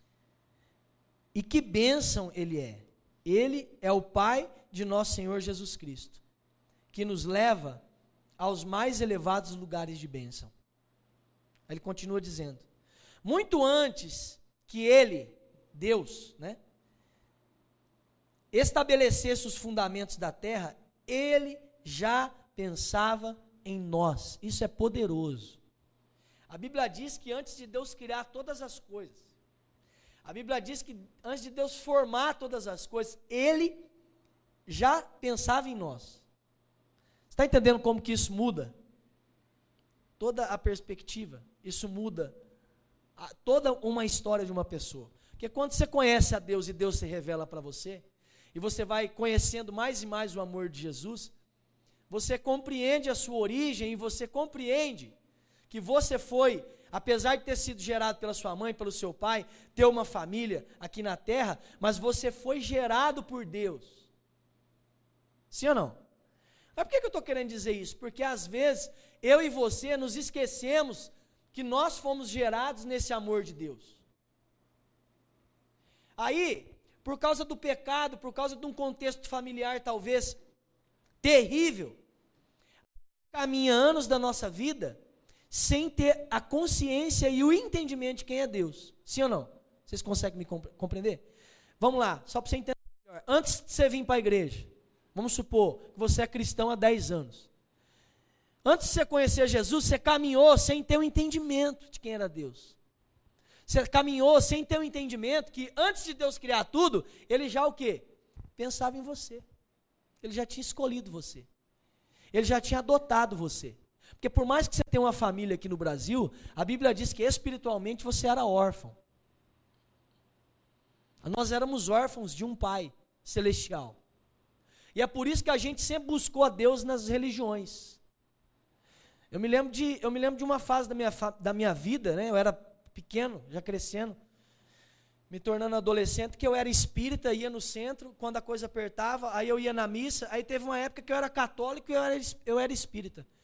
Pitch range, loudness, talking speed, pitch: 190-265 Hz, -30 LUFS, 155 wpm, 230 Hz